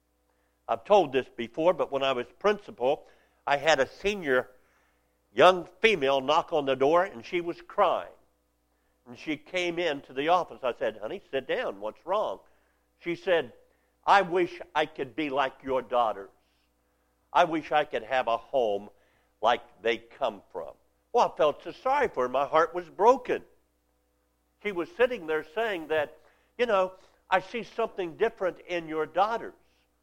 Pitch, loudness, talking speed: 150 Hz, -28 LUFS, 165 wpm